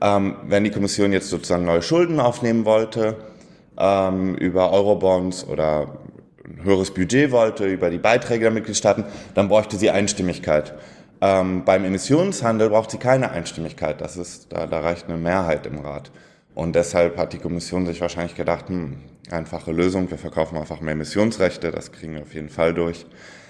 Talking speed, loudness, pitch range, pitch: 170 wpm, -21 LUFS, 85-105 Hz, 95 Hz